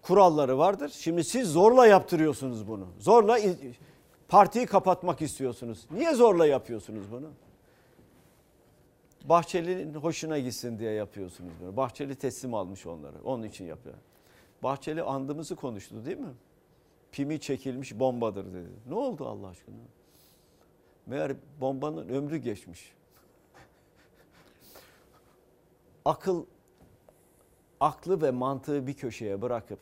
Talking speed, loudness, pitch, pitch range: 105 wpm, -27 LUFS, 135 Hz, 110-165 Hz